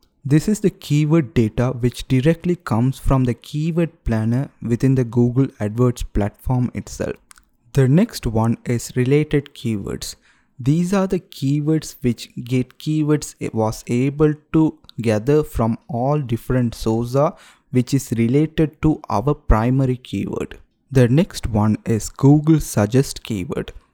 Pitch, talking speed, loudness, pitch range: 130 Hz, 135 wpm, -20 LUFS, 115-150 Hz